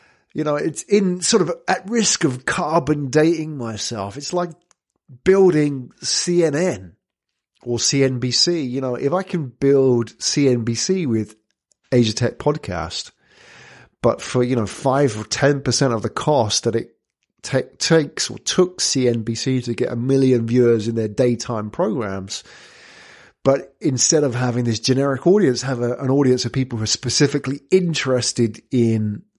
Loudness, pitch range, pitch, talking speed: -19 LUFS, 120-155 Hz, 130 Hz, 150 wpm